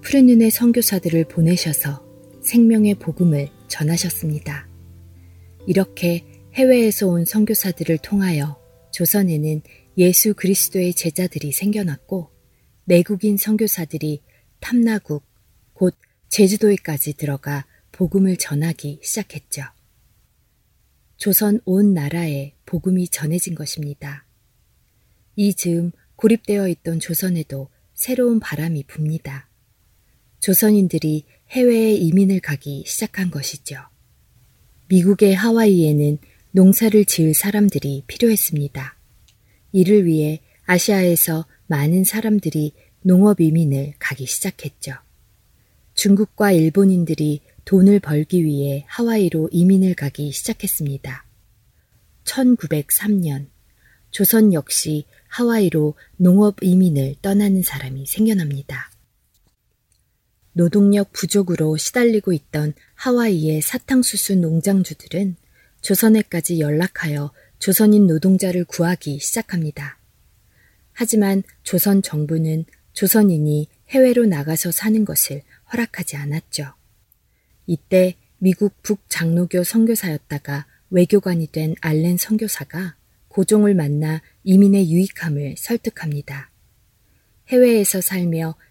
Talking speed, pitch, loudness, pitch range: 255 characters per minute, 170 Hz, -18 LUFS, 145-200 Hz